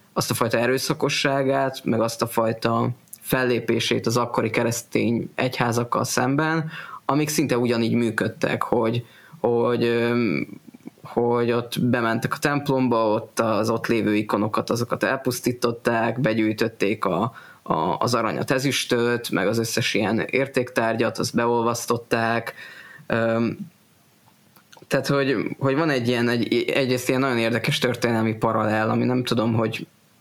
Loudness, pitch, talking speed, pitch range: -23 LUFS, 120 Hz, 125 wpm, 115-130 Hz